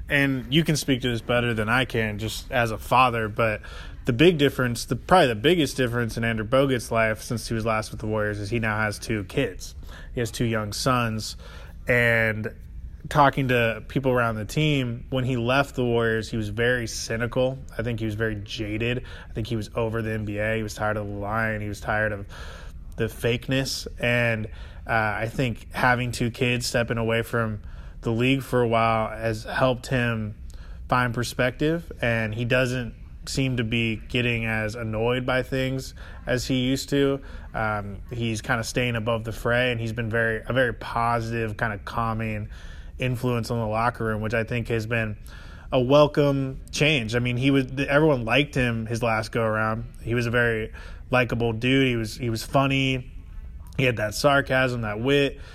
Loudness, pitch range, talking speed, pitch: -24 LUFS, 110-125 Hz, 195 wpm, 115 Hz